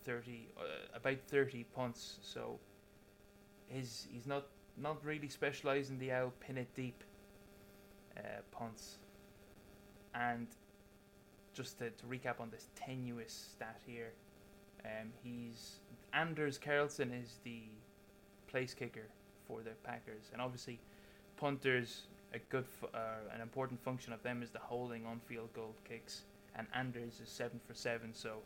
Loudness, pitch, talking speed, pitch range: -45 LUFS, 120 Hz, 140 wpm, 115-130 Hz